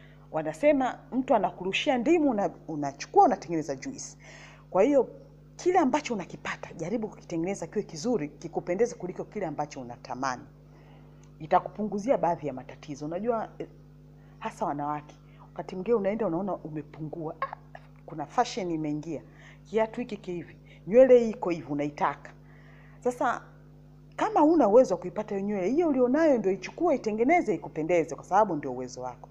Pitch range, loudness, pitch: 150-225 Hz, -28 LUFS, 175 Hz